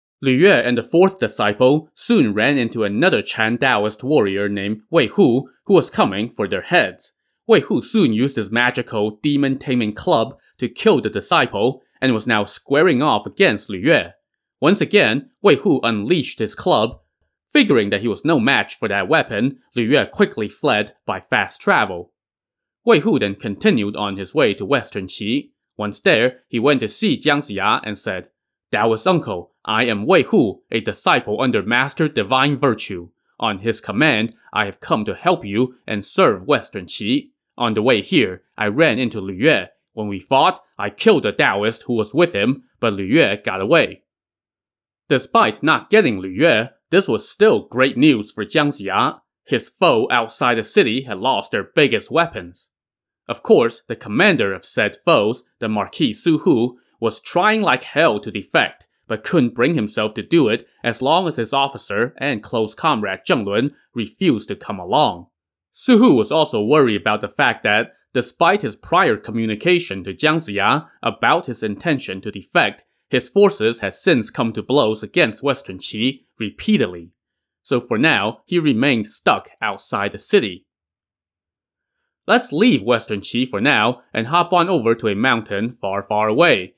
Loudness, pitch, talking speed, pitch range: -18 LUFS, 115 Hz, 175 wpm, 105-145 Hz